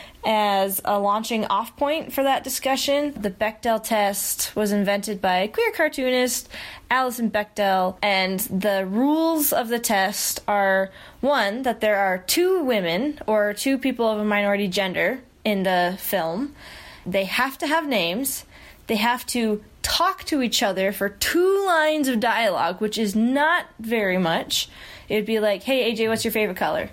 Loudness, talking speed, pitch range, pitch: -22 LUFS, 160 wpm, 200-270 Hz, 225 Hz